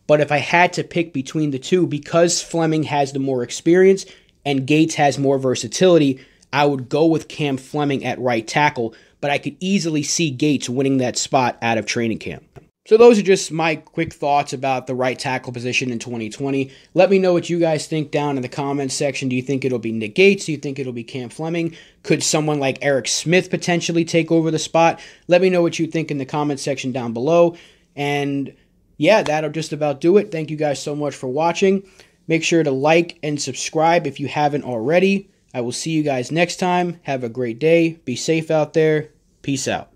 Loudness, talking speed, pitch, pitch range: -19 LUFS, 220 wpm, 150 Hz, 135-165 Hz